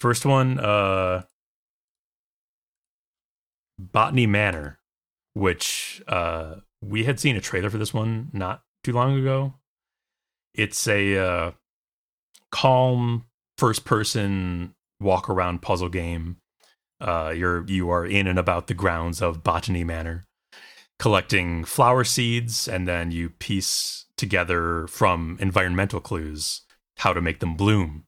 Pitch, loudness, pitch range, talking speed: 95 Hz, -23 LUFS, 85-110 Hz, 120 wpm